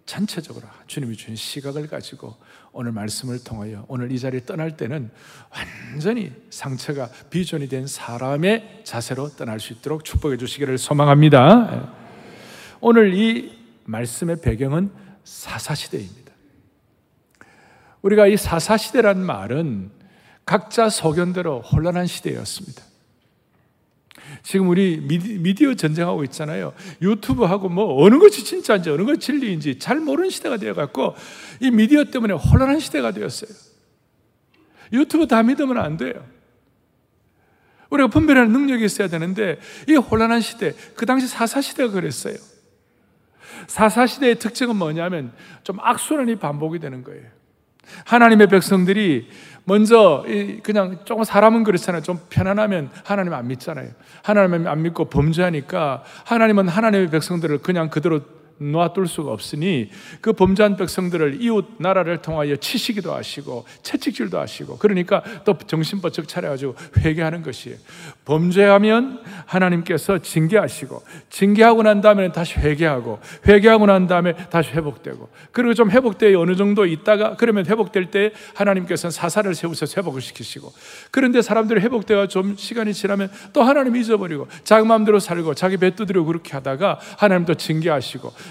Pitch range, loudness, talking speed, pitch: 155-215 Hz, -18 LUFS, 340 characters per minute, 185 Hz